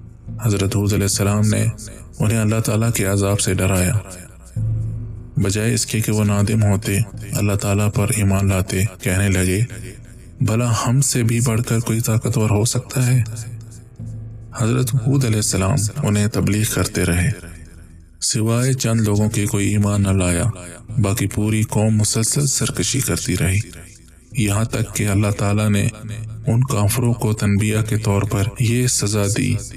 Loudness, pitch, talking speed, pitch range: -19 LUFS, 110 Hz, 155 wpm, 100-115 Hz